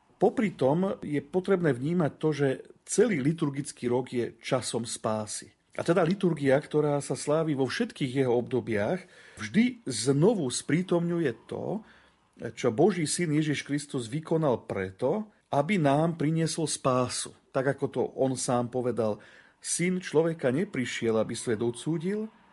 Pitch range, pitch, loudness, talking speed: 125-170 Hz, 145 Hz, -28 LUFS, 135 wpm